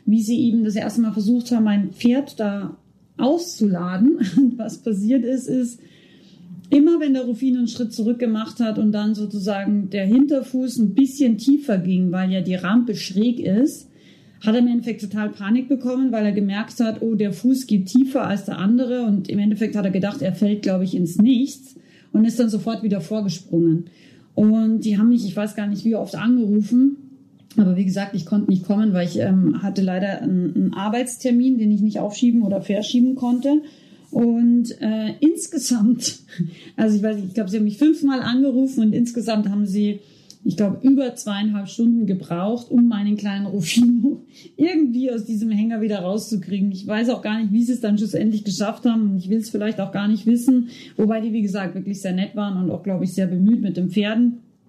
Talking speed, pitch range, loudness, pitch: 200 wpm, 200-245 Hz, -20 LUFS, 220 Hz